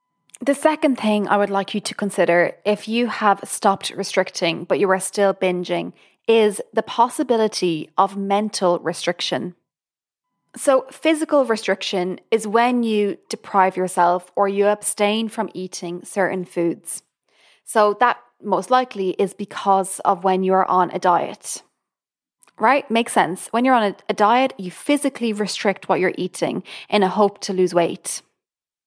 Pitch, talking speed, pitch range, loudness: 200 Hz, 155 wpm, 185-225 Hz, -20 LUFS